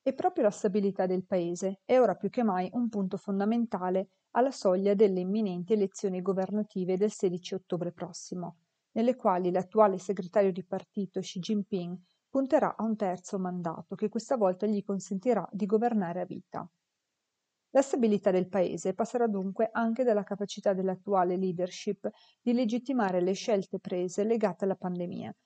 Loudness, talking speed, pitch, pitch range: -30 LUFS, 155 wpm, 200 Hz, 185-220 Hz